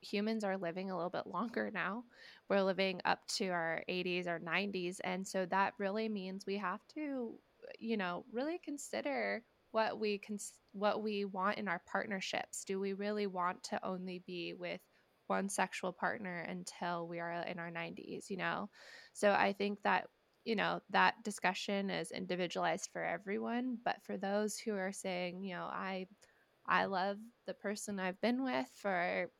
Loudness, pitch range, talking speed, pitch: -38 LUFS, 180-210 Hz, 175 wpm, 195 Hz